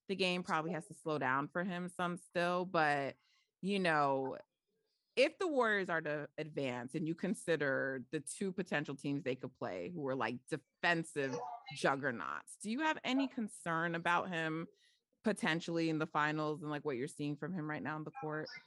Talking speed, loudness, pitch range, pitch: 185 wpm, -38 LUFS, 145-180 Hz, 160 Hz